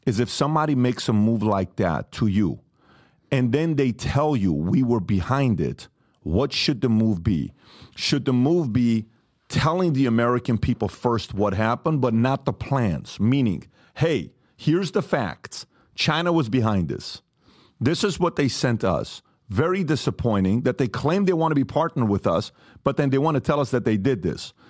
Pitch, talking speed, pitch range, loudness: 130 Hz, 185 wpm, 115-150 Hz, -23 LUFS